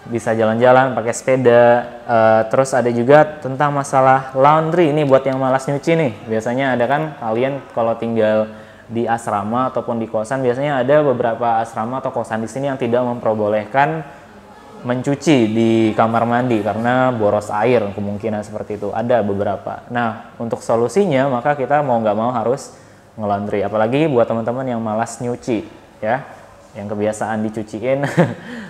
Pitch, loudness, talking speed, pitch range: 120 Hz, -17 LUFS, 150 wpm, 110-135 Hz